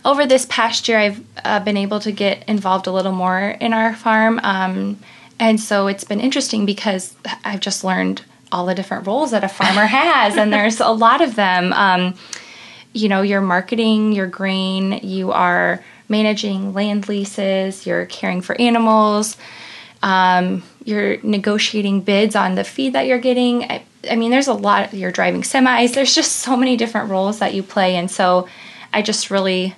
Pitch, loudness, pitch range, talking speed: 205 Hz, -17 LUFS, 190-225 Hz, 185 wpm